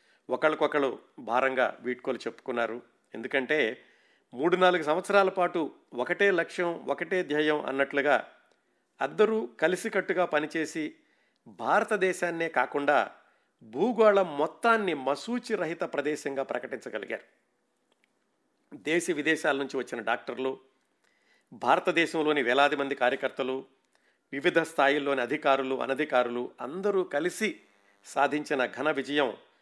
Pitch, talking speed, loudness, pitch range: 150 Hz, 85 wpm, -28 LUFS, 135-180 Hz